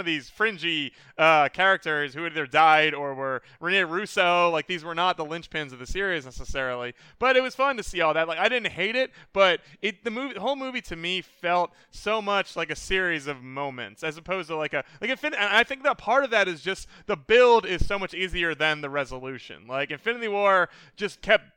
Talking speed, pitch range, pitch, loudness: 230 wpm, 155-205 Hz, 175 Hz, -25 LUFS